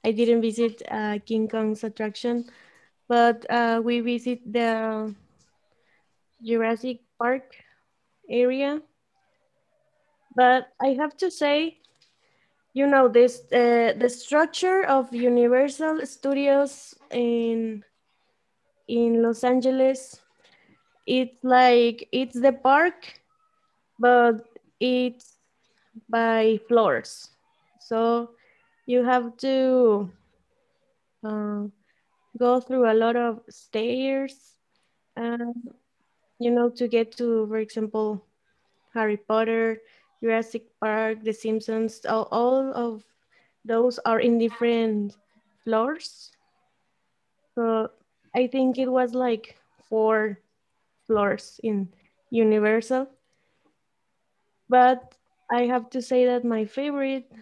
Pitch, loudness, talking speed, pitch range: 240 Hz, -24 LUFS, 95 wpm, 225-260 Hz